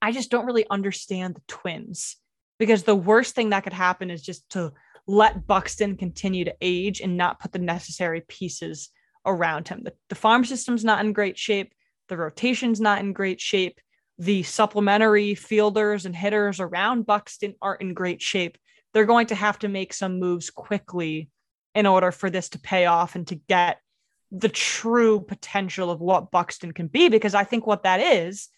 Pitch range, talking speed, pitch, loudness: 180-215 Hz, 185 wpm, 195 Hz, -23 LUFS